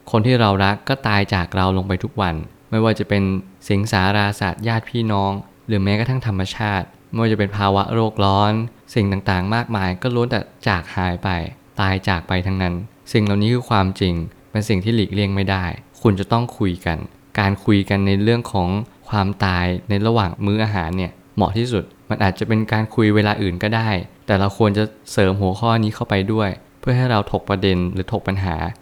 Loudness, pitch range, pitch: -20 LUFS, 95-110 Hz, 100 Hz